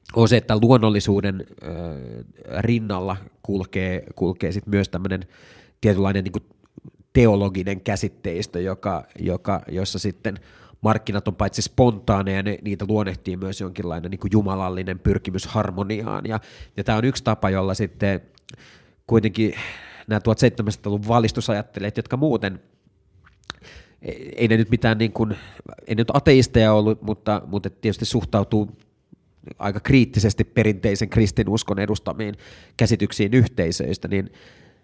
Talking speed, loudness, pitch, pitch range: 120 wpm, -22 LUFS, 105 Hz, 95-110 Hz